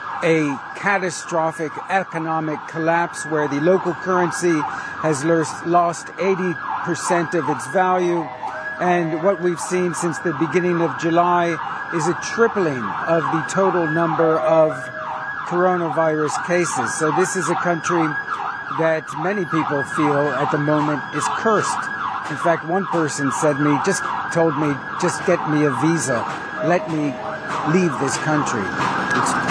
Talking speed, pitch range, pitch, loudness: 140 wpm, 155-175 Hz, 165 Hz, -20 LUFS